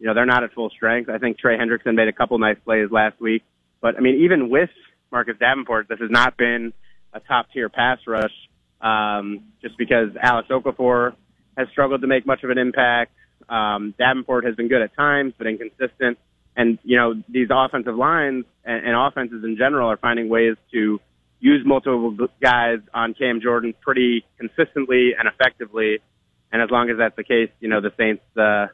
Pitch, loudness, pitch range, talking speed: 120 Hz, -20 LUFS, 110-125 Hz, 190 wpm